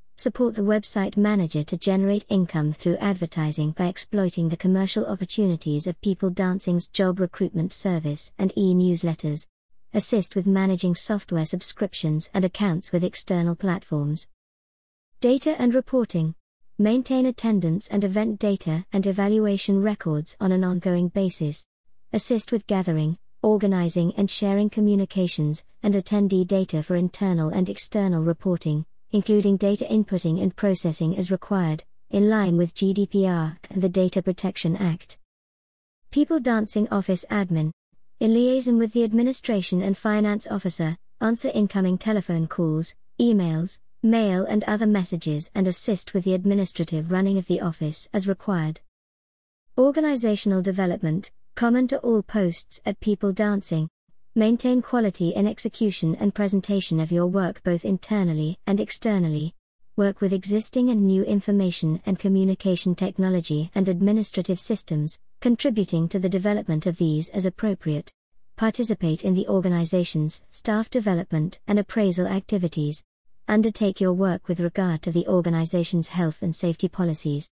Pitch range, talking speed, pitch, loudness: 170-210 Hz, 135 wpm, 190 Hz, -24 LUFS